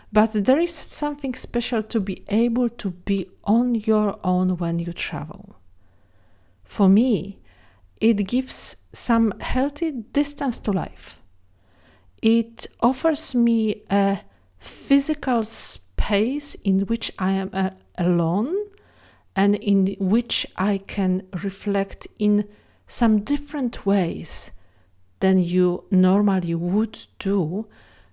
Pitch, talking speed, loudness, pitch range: 200 Hz, 110 wpm, -22 LUFS, 175-230 Hz